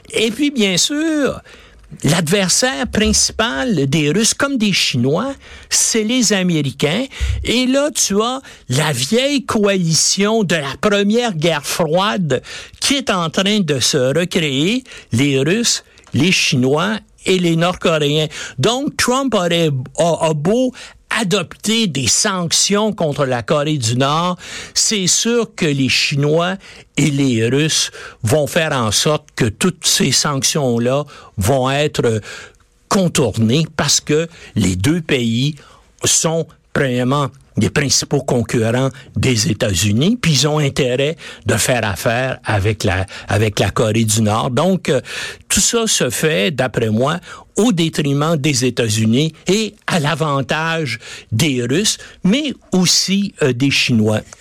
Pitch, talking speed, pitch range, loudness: 155 Hz, 135 wpm, 130-195 Hz, -16 LUFS